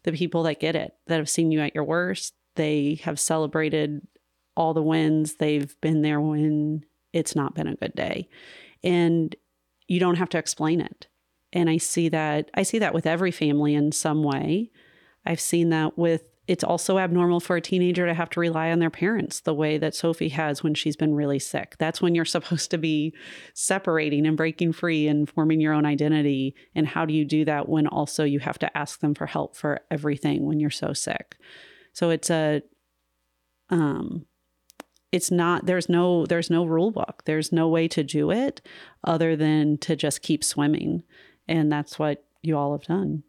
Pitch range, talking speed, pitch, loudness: 150-170 Hz, 195 wpm, 155 Hz, -24 LUFS